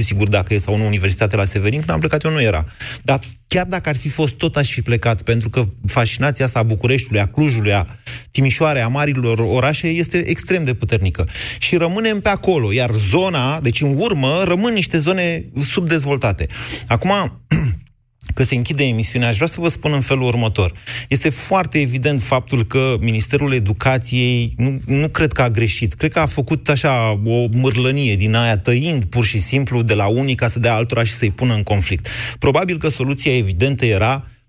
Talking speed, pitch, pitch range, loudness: 190 wpm, 125 Hz, 115-145 Hz, -17 LUFS